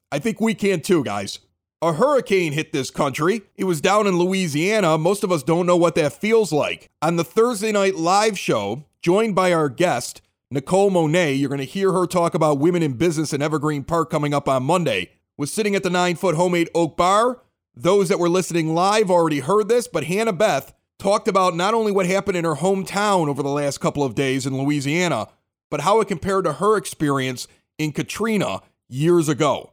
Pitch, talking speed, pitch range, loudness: 175 Hz, 205 wpm, 150-195 Hz, -20 LUFS